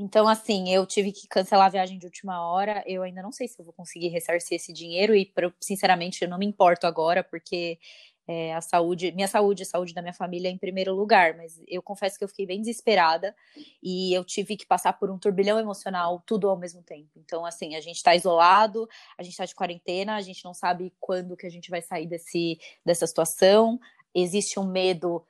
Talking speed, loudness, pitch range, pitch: 220 wpm, -25 LUFS, 175-200 Hz, 185 Hz